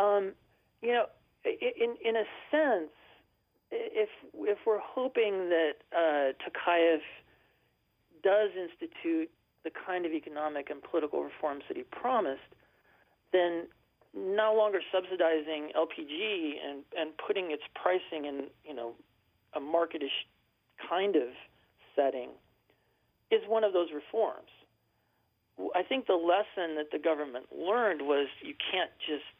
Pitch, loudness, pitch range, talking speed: 180 Hz, -32 LUFS, 150-225 Hz, 125 wpm